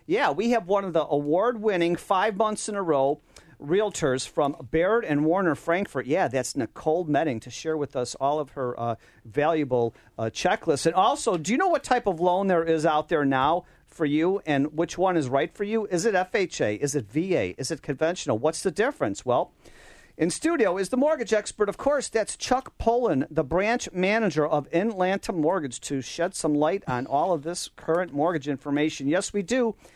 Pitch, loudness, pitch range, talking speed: 165 Hz, -25 LUFS, 145-195 Hz, 200 wpm